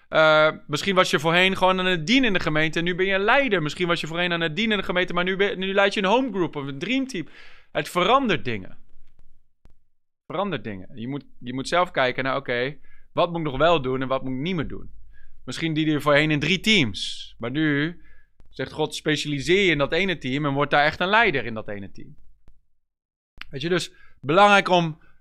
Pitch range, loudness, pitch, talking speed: 135-185 Hz, -22 LUFS, 160 Hz, 235 wpm